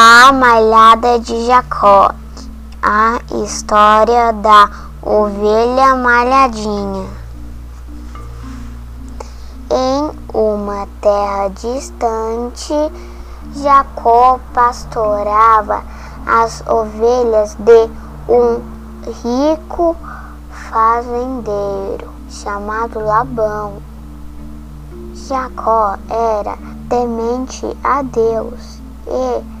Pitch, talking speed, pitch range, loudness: 225 Hz, 60 wpm, 200-240 Hz, -13 LUFS